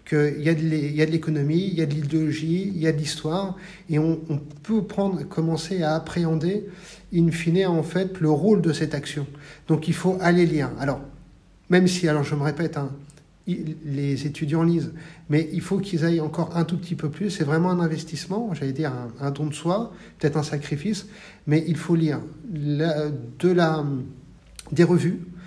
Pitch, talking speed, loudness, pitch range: 160 Hz, 195 wpm, -24 LUFS, 150-175 Hz